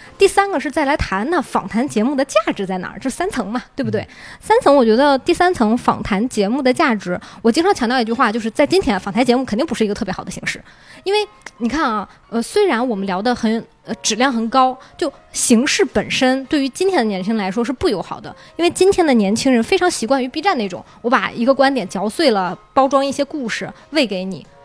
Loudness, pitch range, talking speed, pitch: -17 LUFS, 225-300 Hz, 350 characters per minute, 255 Hz